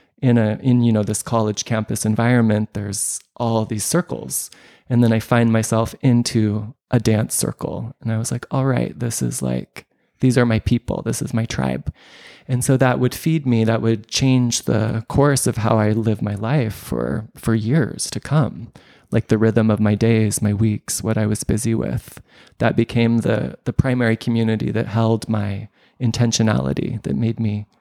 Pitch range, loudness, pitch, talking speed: 110-120 Hz, -19 LUFS, 115 Hz, 190 wpm